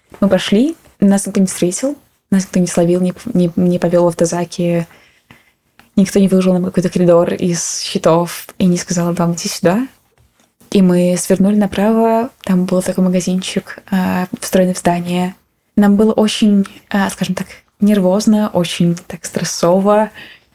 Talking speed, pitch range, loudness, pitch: 145 wpm, 175-205 Hz, -15 LUFS, 185 Hz